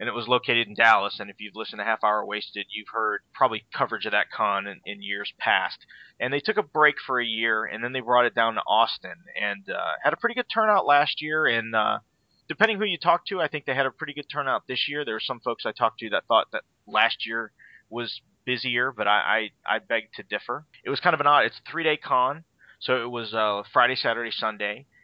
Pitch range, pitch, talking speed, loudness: 115-150 Hz, 125 Hz, 250 wpm, -25 LUFS